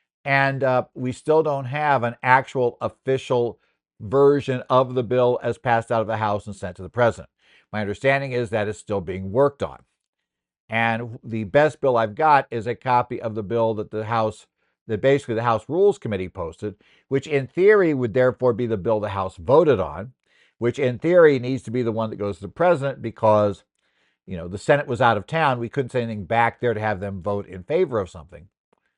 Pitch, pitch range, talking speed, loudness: 120 Hz, 110-130 Hz, 215 wpm, -22 LUFS